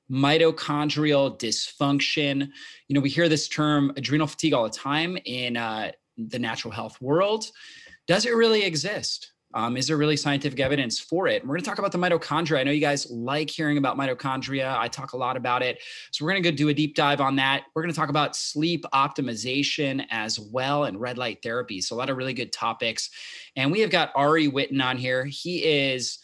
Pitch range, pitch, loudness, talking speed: 130-155 Hz, 145 Hz, -25 LUFS, 210 wpm